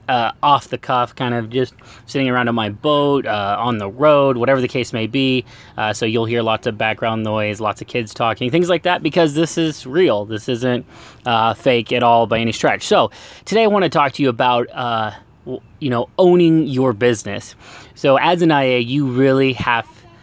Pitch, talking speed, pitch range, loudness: 125 Hz, 205 wpm, 115-140 Hz, -17 LUFS